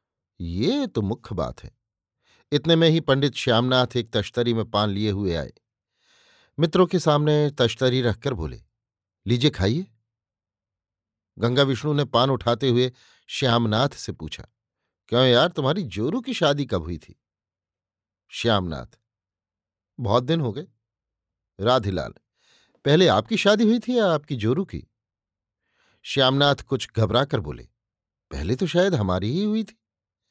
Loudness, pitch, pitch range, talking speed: -22 LUFS, 120 Hz, 105-140 Hz, 140 wpm